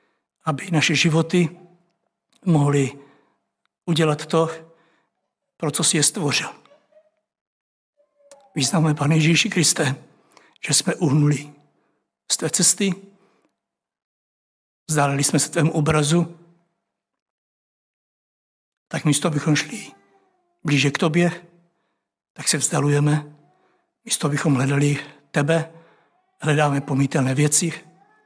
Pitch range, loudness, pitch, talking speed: 145-175 Hz, -20 LUFS, 160 Hz, 90 wpm